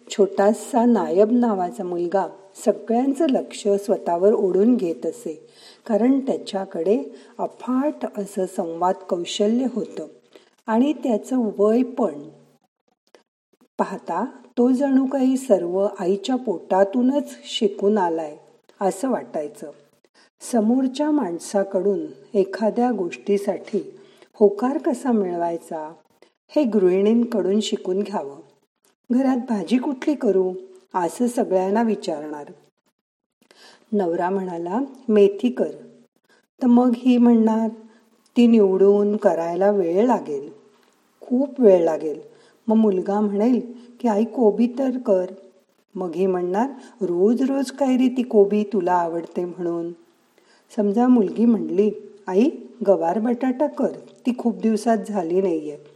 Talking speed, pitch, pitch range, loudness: 105 wpm, 210 Hz, 190-245 Hz, -21 LUFS